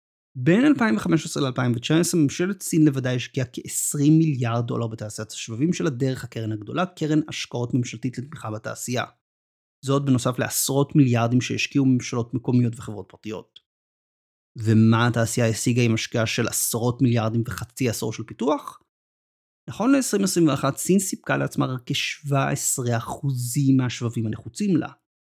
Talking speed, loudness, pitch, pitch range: 125 wpm, -23 LUFS, 125 Hz, 115-145 Hz